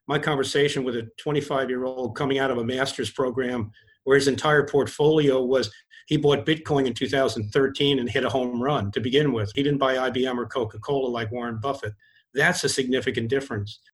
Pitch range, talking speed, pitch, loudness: 125-140 Hz, 195 wpm, 135 Hz, -24 LUFS